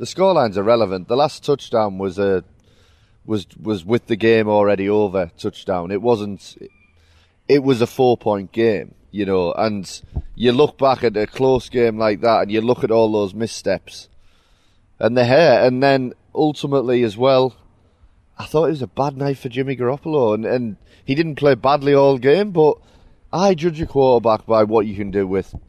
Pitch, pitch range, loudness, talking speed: 115 Hz, 100-135 Hz, -18 LUFS, 190 wpm